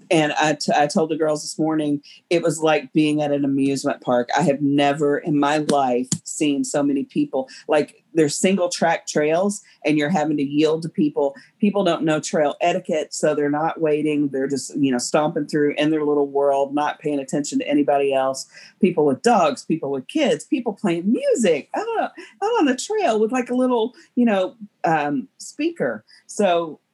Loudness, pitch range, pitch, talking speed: -21 LUFS, 145-195 Hz, 155 Hz, 195 wpm